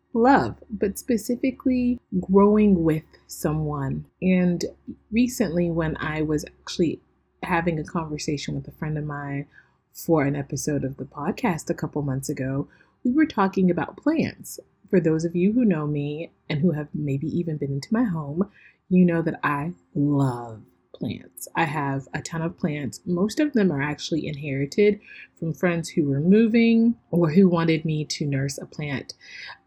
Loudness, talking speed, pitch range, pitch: -24 LUFS, 165 wpm, 150-195 Hz, 165 Hz